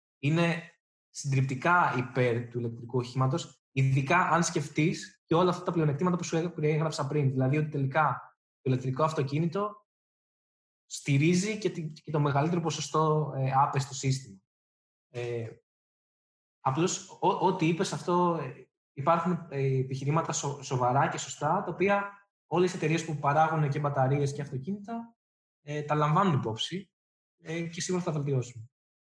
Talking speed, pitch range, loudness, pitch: 130 wpm, 135-170 Hz, -29 LUFS, 155 Hz